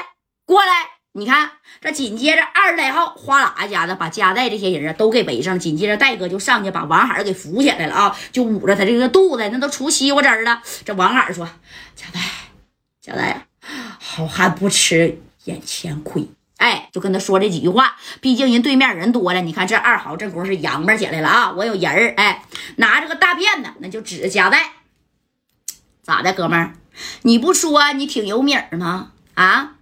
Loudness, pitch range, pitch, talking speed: -16 LUFS, 185-275 Hz, 215 Hz, 280 characters per minute